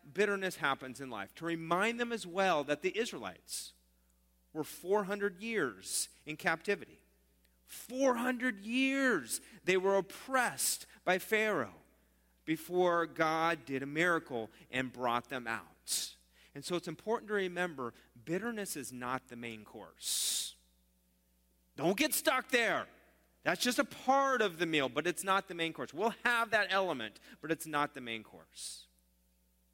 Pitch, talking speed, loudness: 165 Hz, 145 wpm, -34 LUFS